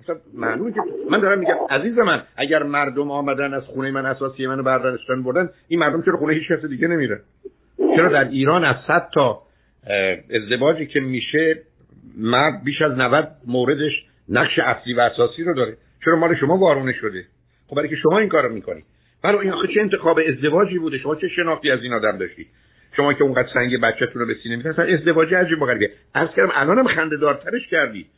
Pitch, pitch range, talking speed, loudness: 150 Hz, 130-170 Hz, 165 wpm, -19 LUFS